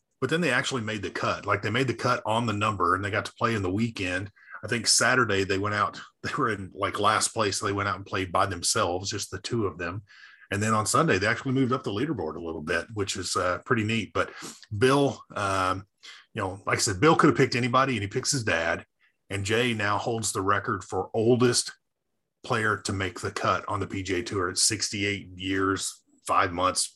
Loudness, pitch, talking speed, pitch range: -26 LUFS, 110 Hz, 235 wpm, 95-120 Hz